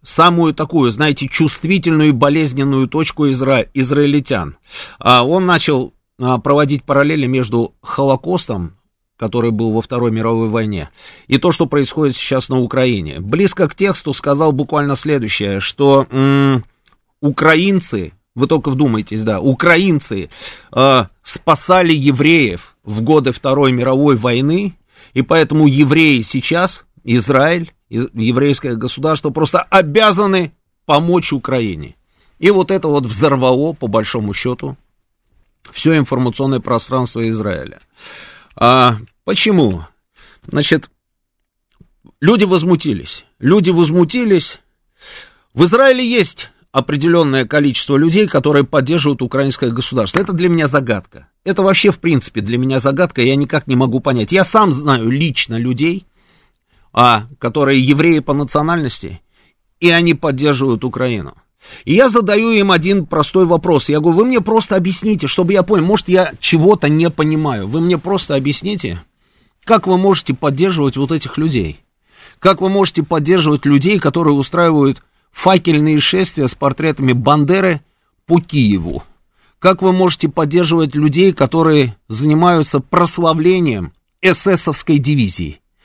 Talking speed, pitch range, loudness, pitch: 120 wpm, 125-170 Hz, -13 LUFS, 145 Hz